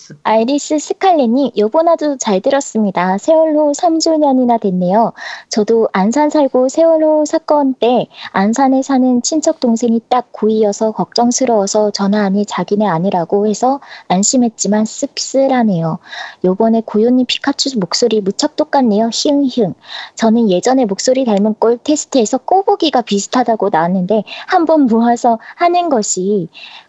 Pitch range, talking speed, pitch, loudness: 210-280 Hz, 315 characters per minute, 240 Hz, -13 LUFS